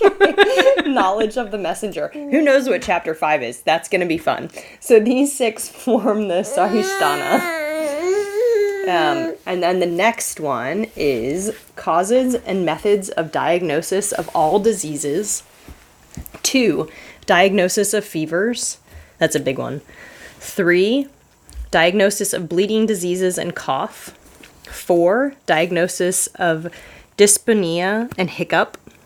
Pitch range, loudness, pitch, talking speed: 175-265 Hz, -18 LUFS, 205 Hz, 120 wpm